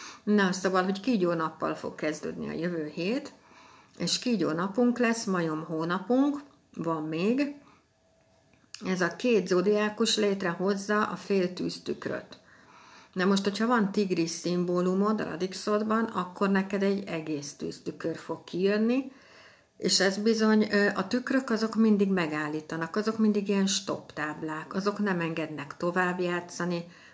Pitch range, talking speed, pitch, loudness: 170-215 Hz, 130 wpm, 195 Hz, -28 LUFS